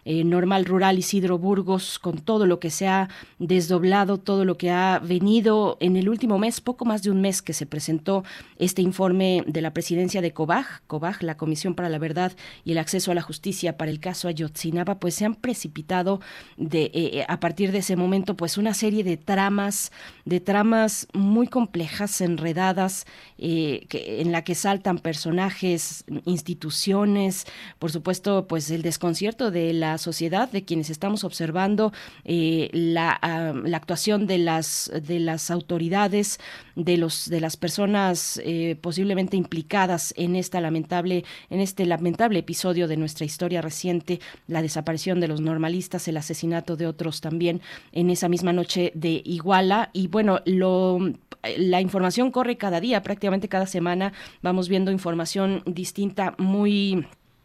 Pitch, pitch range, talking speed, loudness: 180 Hz, 165-195 Hz, 160 wpm, -24 LUFS